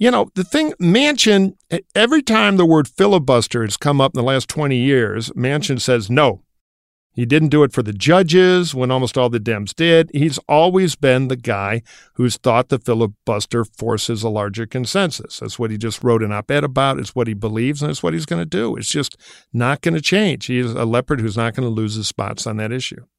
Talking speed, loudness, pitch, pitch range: 220 wpm, -17 LUFS, 125 Hz, 115-155 Hz